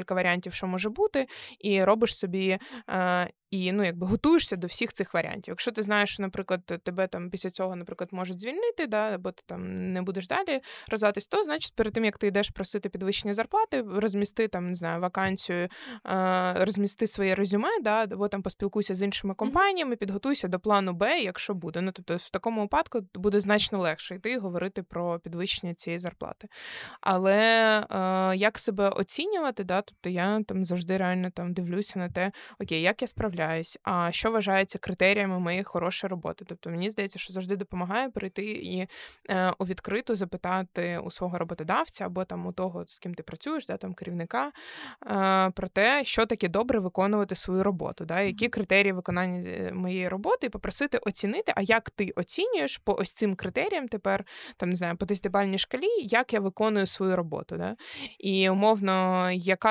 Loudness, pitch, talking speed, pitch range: -28 LUFS, 195 Hz, 175 wpm, 185-215 Hz